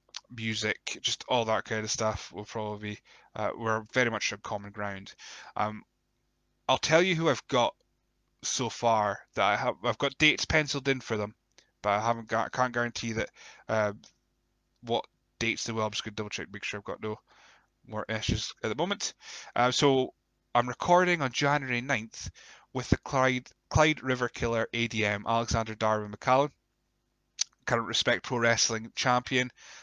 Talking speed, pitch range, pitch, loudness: 170 wpm, 110-125 Hz, 115 Hz, -29 LUFS